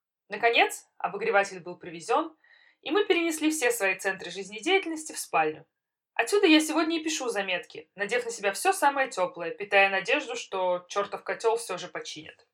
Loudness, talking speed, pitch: -27 LUFS, 160 wpm, 215 Hz